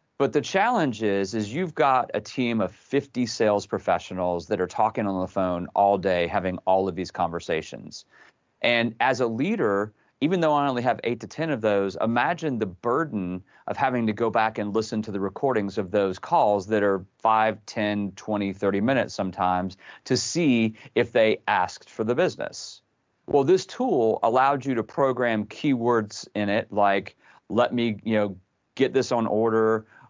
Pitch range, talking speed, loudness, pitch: 100-120 Hz, 180 wpm, -25 LUFS, 110 Hz